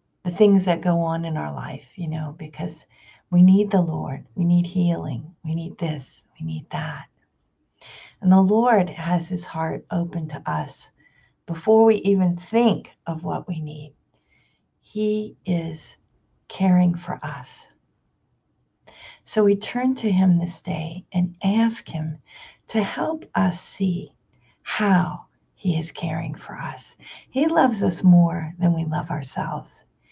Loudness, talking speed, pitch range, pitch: -22 LUFS, 145 wpm, 155-190 Hz, 175 Hz